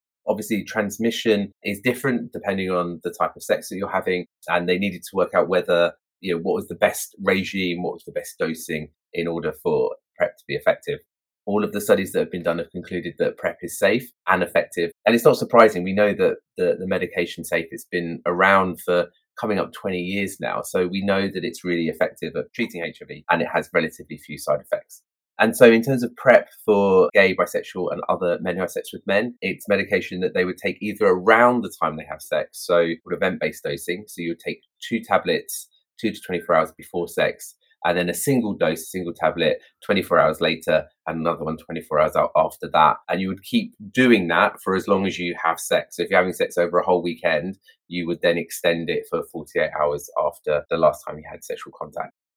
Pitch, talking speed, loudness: 110 Hz, 220 wpm, -22 LUFS